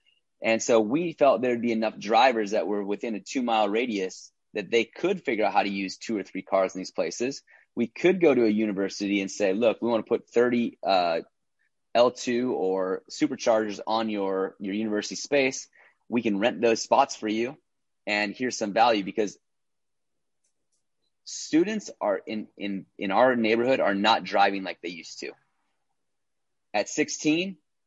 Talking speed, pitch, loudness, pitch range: 170 wpm, 115 Hz, -26 LUFS, 100-125 Hz